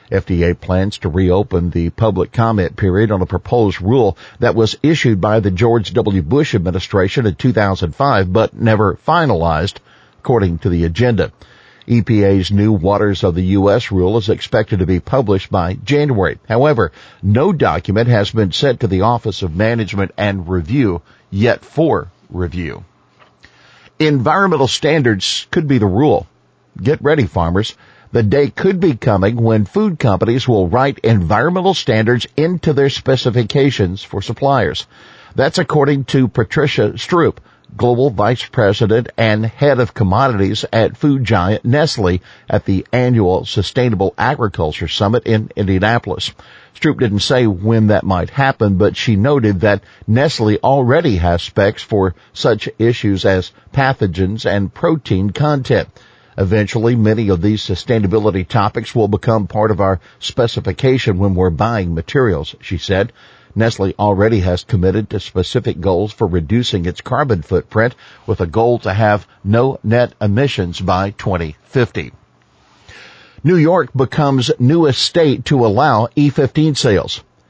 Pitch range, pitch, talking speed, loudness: 95-125 Hz, 110 Hz, 140 wpm, -15 LUFS